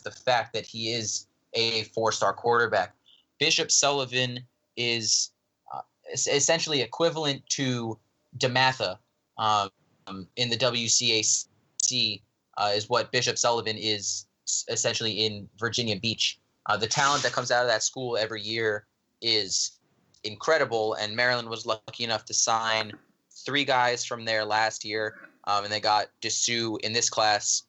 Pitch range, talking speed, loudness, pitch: 110-125 Hz, 140 wpm, -26 LUFS, 115 Hz